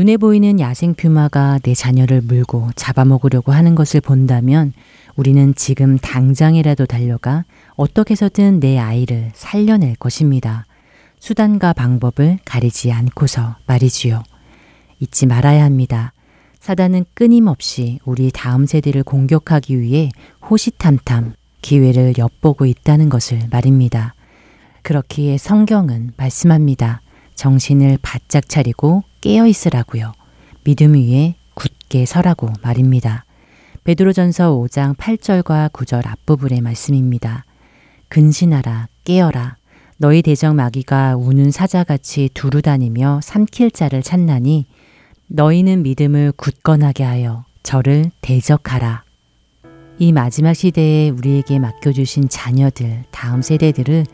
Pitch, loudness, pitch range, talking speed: 140 Hz, -14 LUFS, 125-155 Hz, 280 characters per minute